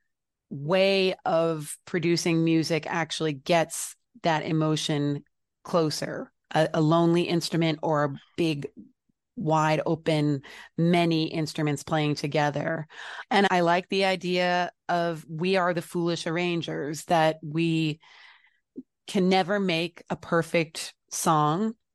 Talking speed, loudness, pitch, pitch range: 110 wpm, -26 LUFS, 165 Hz, 155-175 Hz